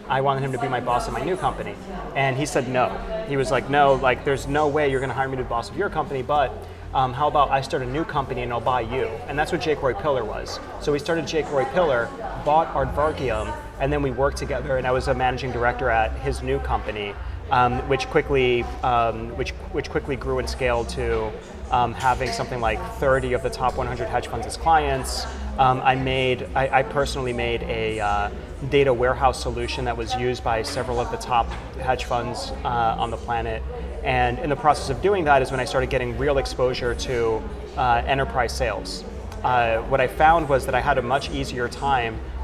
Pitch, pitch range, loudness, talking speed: 130 Hz, 120-135 Hz, -23 LUFS, 220 wpm